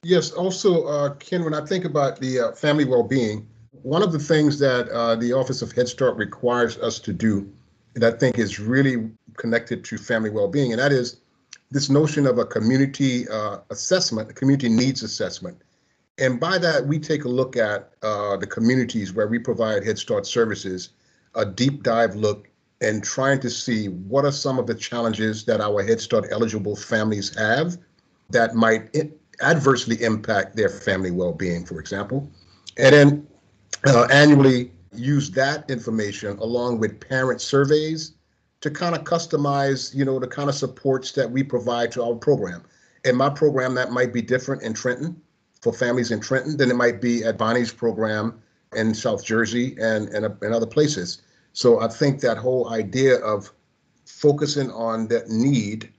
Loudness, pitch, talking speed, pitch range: -22 LUFS, 125 Hz, 175 wpm, 110-140 Hz